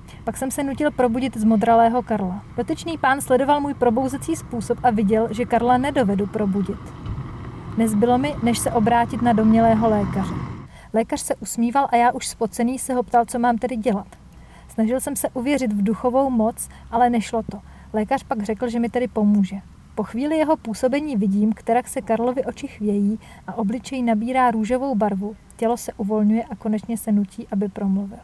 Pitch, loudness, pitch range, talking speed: 235 Hz, -21 LUFS, 215-255 Hz, 175 wpm